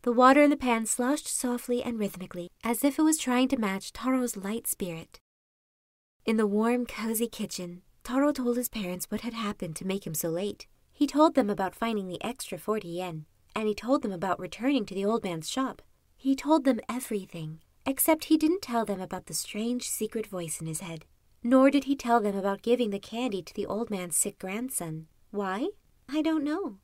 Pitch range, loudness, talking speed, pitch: 190-255 Hz, -29 LUFS, 205 wpm, 225 Hz